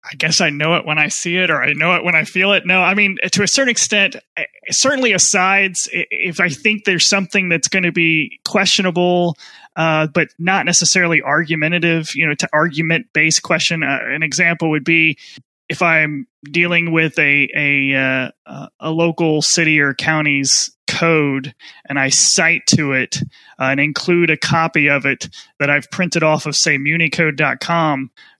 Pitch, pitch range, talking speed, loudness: 165 Hz, 150-180 Hz, 180 wpm, -14 LUFS